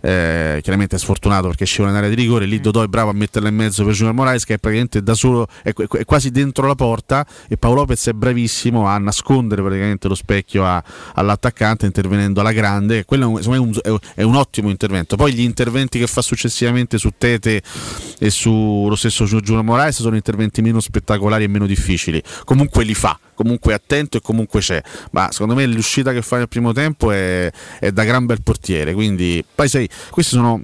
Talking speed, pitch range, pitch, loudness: 205 wpm, 100-120 Hz, 110 Hz, -16 LUFS